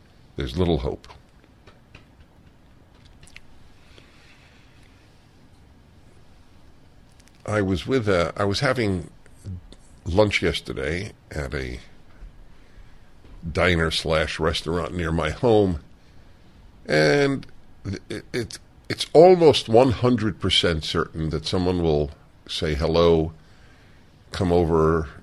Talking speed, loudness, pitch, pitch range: 80 wpm, -22 LUFS, 85 Hz, 80-95 Hz